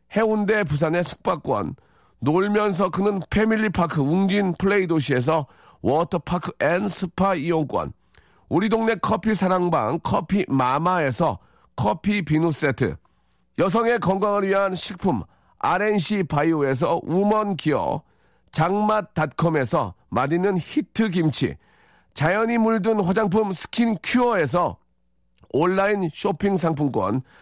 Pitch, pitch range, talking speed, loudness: 185 Hz, 160-210 Hz, 255 characters per minute, -22 LUFS